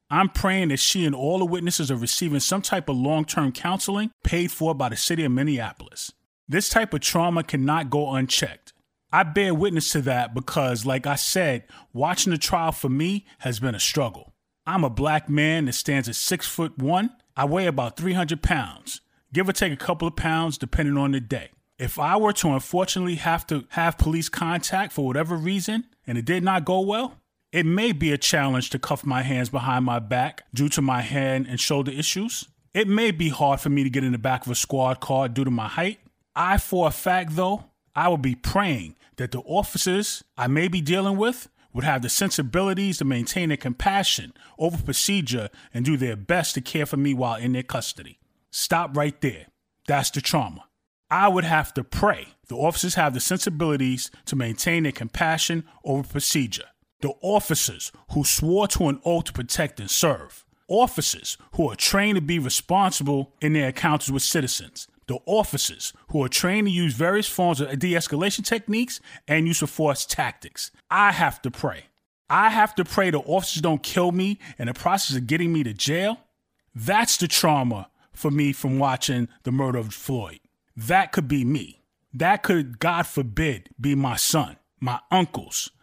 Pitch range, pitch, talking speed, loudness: 130-180 Hz, 150 Hz, 195 wpm, -23 LUFS